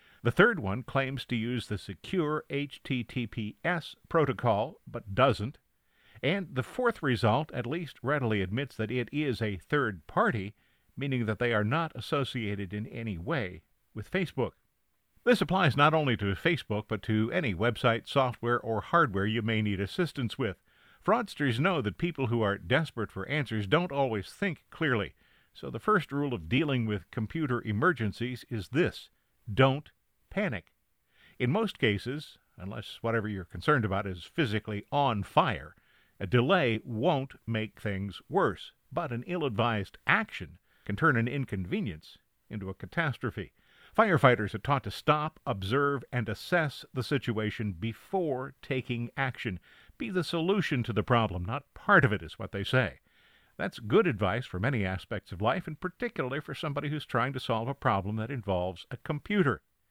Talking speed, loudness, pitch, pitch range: 160 wpm, -30 LUFS, 120 Hz, 105-145 Hz